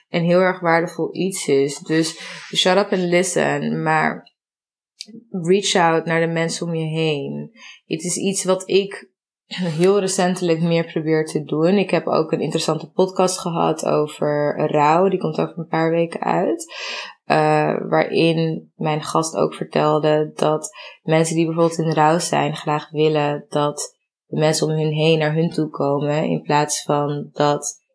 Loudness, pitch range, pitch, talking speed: -19 LUFS, 150-180 Hz, 165 Hz, 165 wpm